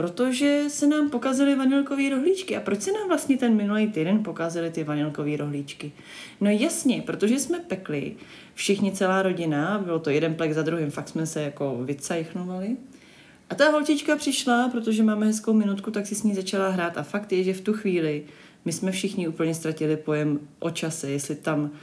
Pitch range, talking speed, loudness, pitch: 160-245 Hz, 185 wpm, -25 LUFS, 190 Hz